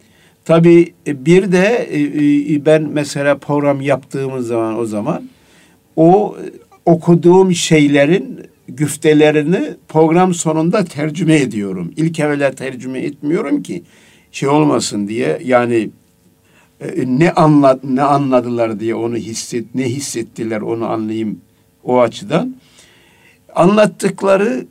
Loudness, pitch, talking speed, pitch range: -14 LUFS, 145 Hz, 100 wpm, 120-165 Hz